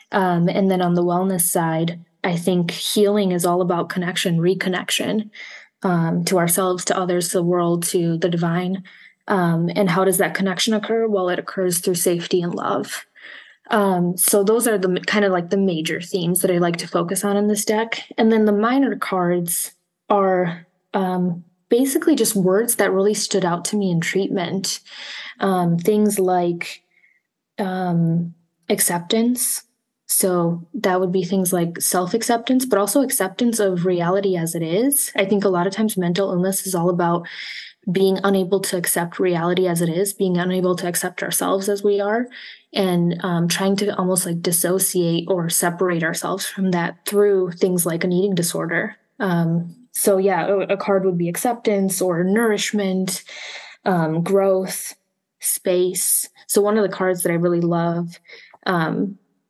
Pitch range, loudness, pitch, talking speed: 175-200 Hz, -20 LUFS, 185 Hz, 170 wpm